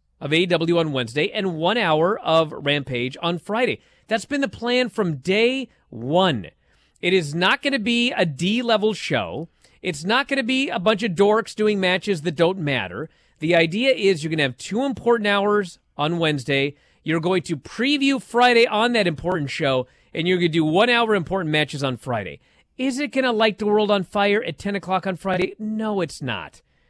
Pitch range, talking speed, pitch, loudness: 160-220 Hz, 205 wpm, 185 Hz, -21 LUFS